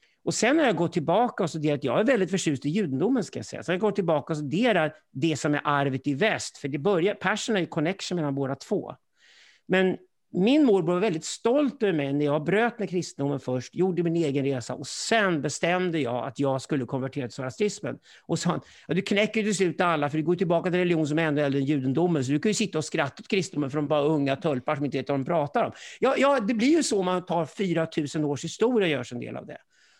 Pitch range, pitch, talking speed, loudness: 145-195 Hz, 165 Hz, 245 wpm, -26 LUFS